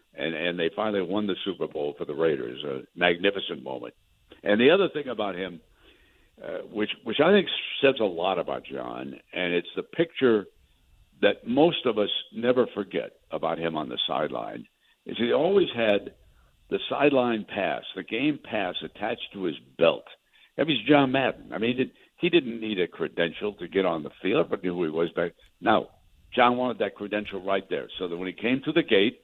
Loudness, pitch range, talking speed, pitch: -26 LUFS, 85-125 Hz, 200 wpm, 100 Hz